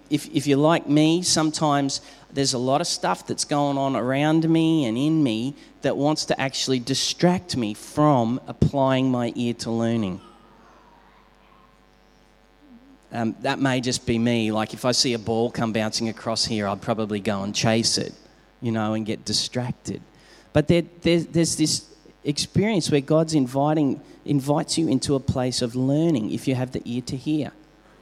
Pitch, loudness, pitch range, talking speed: 135 Hz, -23 LUFS, 115-155 Hz, 175 wpm